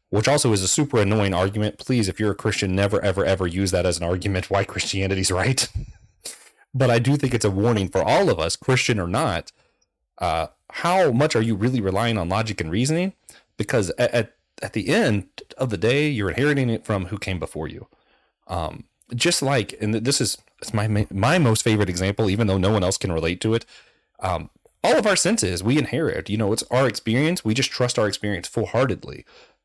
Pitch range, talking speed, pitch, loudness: 95-125 Hz, 210 wpm, 105 Hz, -22 LUFS